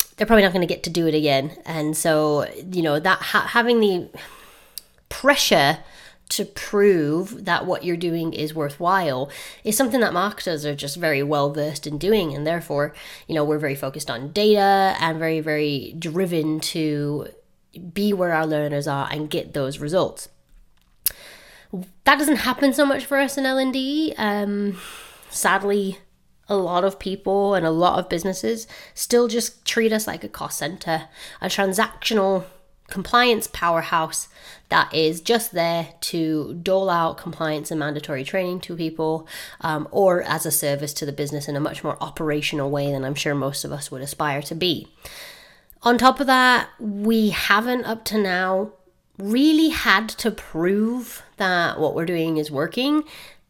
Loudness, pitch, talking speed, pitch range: -21 LUFS, 175 Hz, 165 wpm, 150-205 Hz